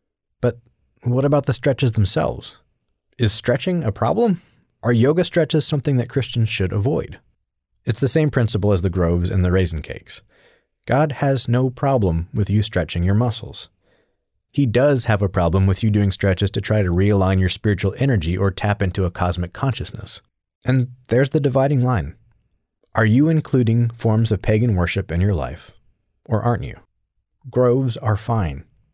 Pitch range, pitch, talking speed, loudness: 95-130 Hz, 110 Hz, 170 wpm, -20 LUFS